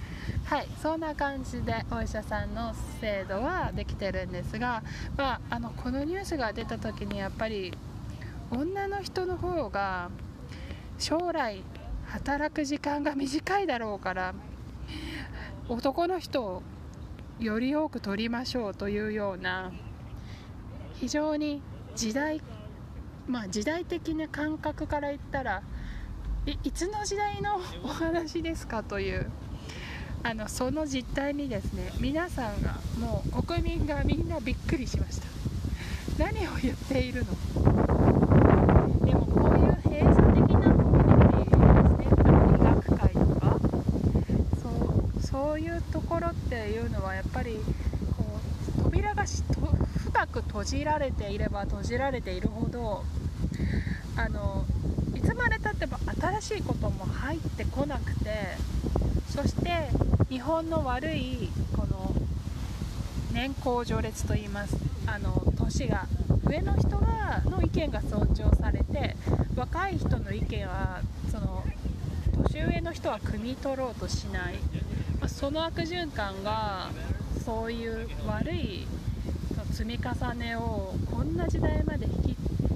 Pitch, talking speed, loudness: 185 Hz, 235 characters per minute, -29 LUFS